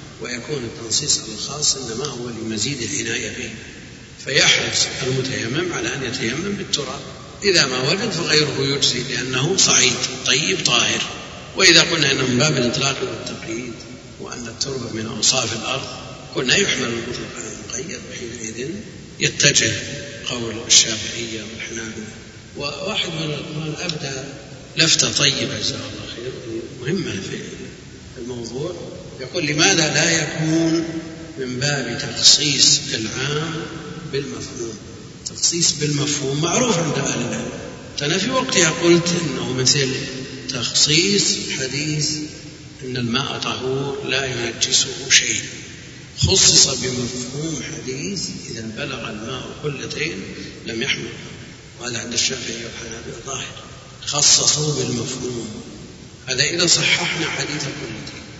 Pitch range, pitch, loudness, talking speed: 120-150 Hz, 135 Hz, -18 LUFS, 110 wpm